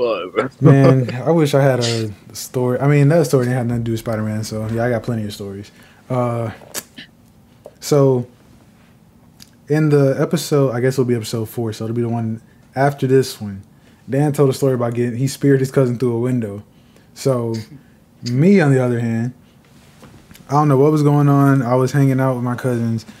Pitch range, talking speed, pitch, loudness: 115-140 Hz, 200 wpm, 125 Hz, -17 LUFS